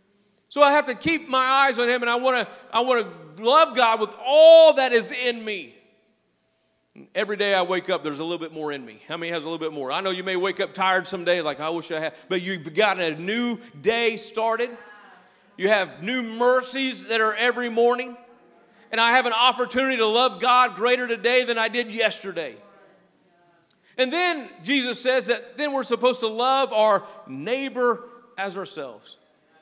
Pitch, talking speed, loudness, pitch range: 225 Hz, 200 wpm, -21 LUFS, 190-250 Hz